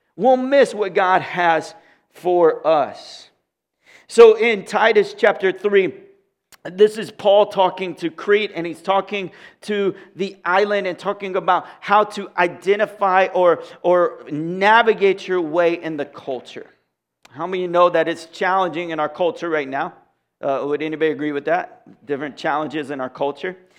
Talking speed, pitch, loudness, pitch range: 155 wpm, 185 Hz, -18 LUFS, 165-205 Hz